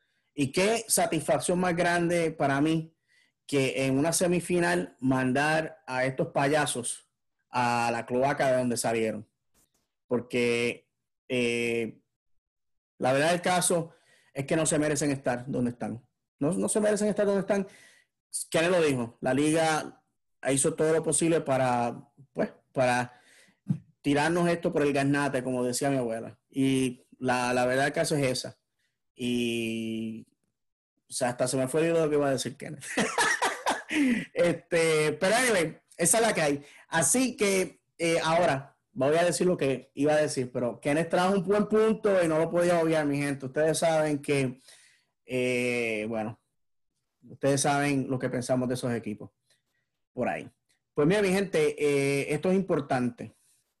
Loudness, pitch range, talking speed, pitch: -27 LUFS, 125-165 Hz, 155 wpm, 145 Hz